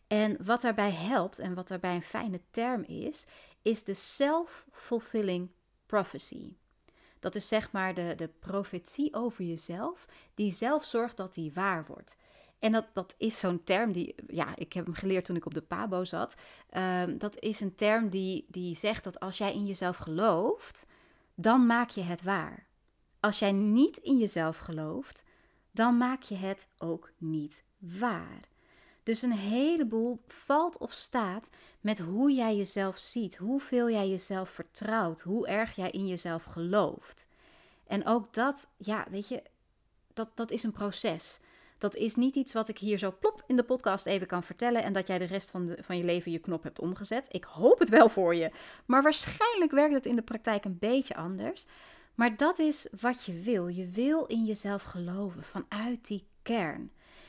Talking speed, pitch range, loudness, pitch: 180 wpm, 185-245 Hz, -31 LUFS, 210 Hz